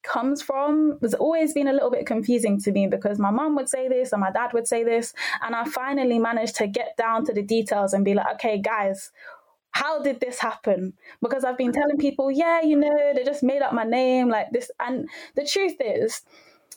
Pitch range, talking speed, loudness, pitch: 225-285 Hz, 220 wpm, -23 LUFS, 255 Hz